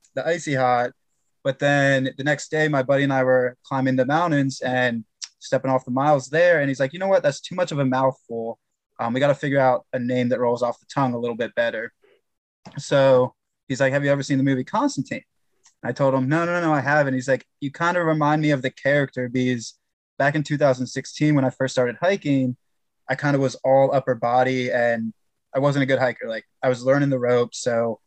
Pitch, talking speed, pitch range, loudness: 135 Hz, 235 wpm, 125-145 Hz, -22 LUFS